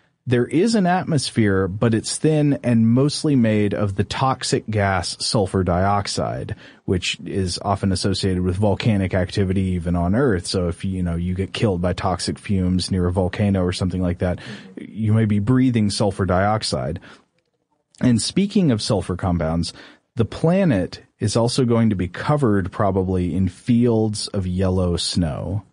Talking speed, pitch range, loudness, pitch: 160 wpm, 95-120 Hz, -20 LUFS, 105 Hz